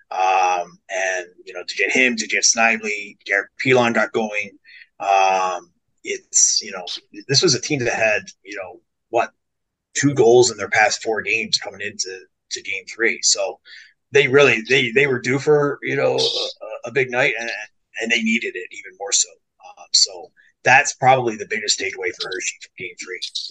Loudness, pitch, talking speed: -18 LUFS, 370 Hz, 185 wpm